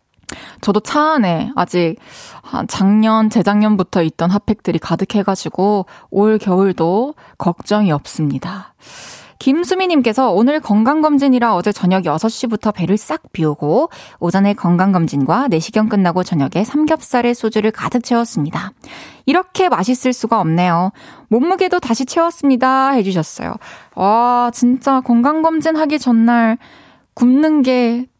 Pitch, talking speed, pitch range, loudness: 220 Hz, 290 characters per minute, 185-260 Hz, -15 LUFS